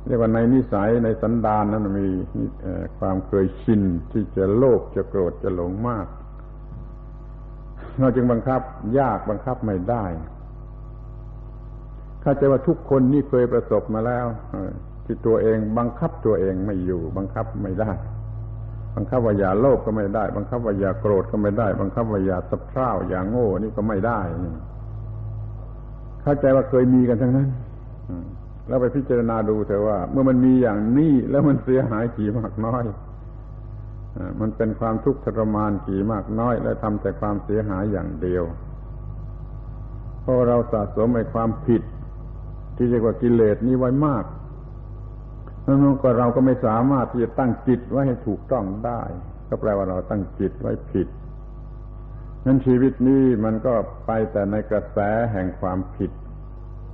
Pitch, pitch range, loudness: 115 Hz, 105-125 Hz, -22 LUFS